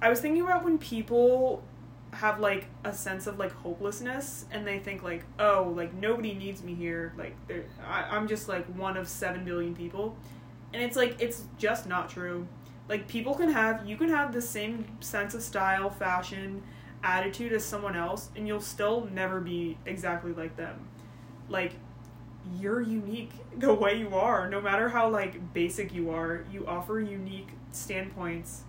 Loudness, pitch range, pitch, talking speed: -31 LUFS, 175-215 Hz, 195 Hz, 175 wpm